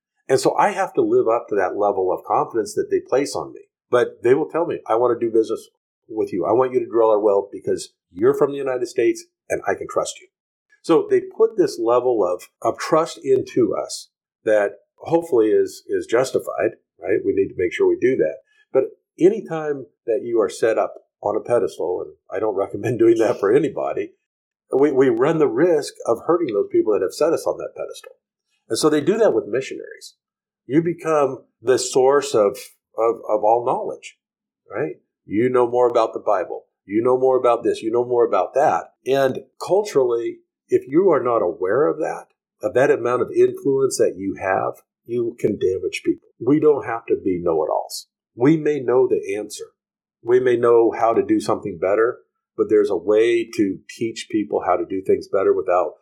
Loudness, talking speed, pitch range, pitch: -20 LUFS, 205 wpm, 355-430 Hz, 400 Hz